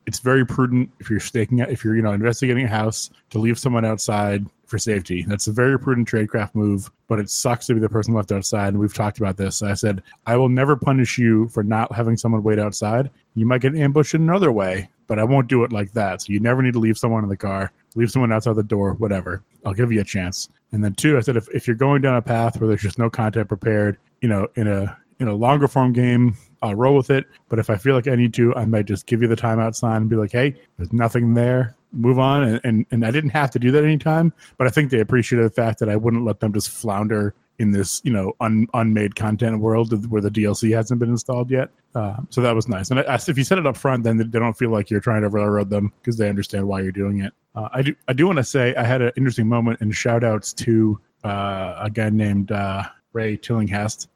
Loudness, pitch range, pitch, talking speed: -20 LUFS, 105-125 Hz, 115 Hz, 265 wpm